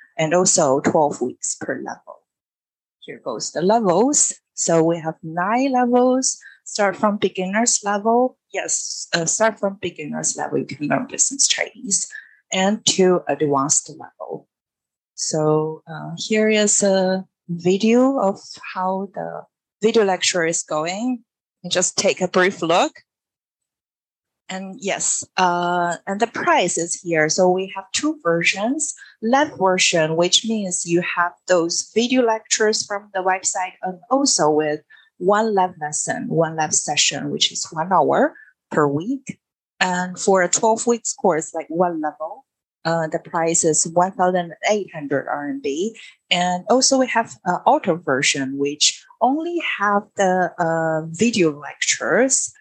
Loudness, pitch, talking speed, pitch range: -19 LUFS, 185 Hz, 145 wpm, 165-215 Hz